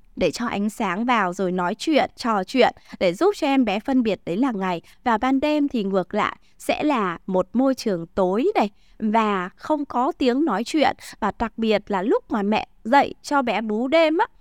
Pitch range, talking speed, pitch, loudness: 200-280 Hz, 215 wpm, 235 Hz, -22 LUFS